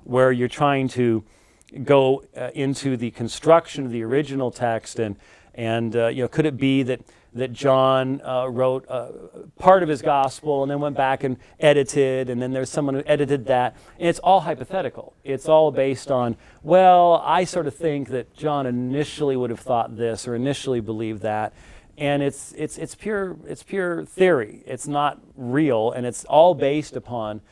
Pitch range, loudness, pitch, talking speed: 120-150 Hz, -21 LUFS, 135 Hz, 185 wpm